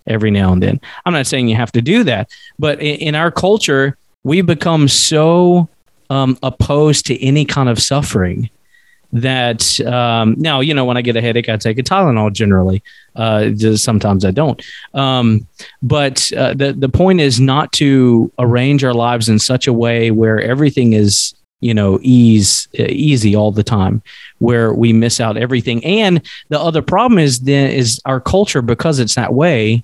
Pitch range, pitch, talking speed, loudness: 115-145 Hz, 125 Hz, 180 wpm, -13 LUFS